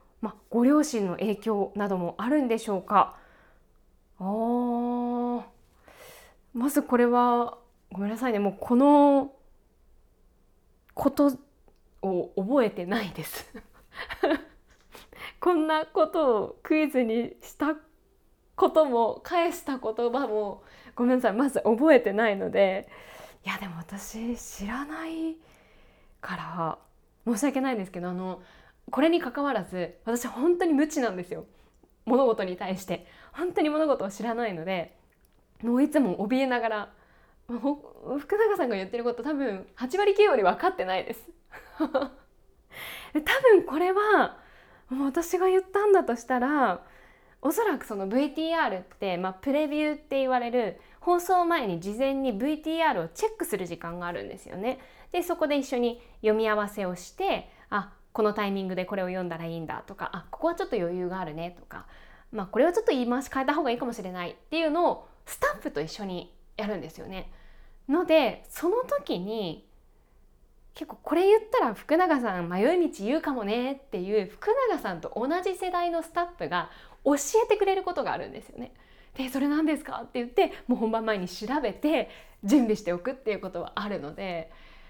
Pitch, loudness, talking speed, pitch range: 255 Hz, -27 LUFS, 305 characters per minute, 210-315 Hz